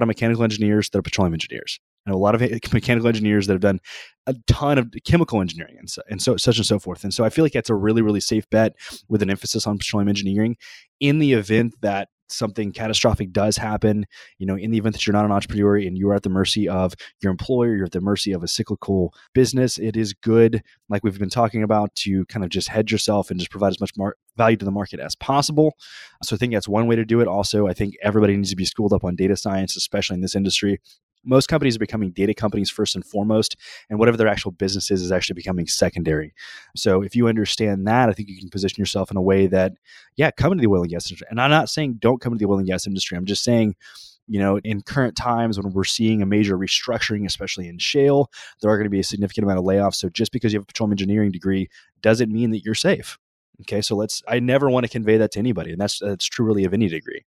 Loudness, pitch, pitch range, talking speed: -21 LUFS, 105 Hz, 95-115 Hz, 260 wpm